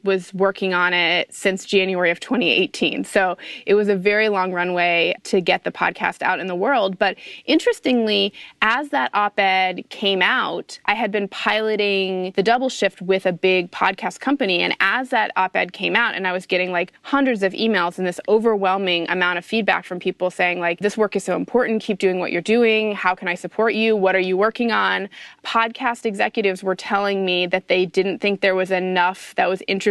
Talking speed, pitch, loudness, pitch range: 205 wpm, 195 Hz, -19 LUFS, 185-215 Hz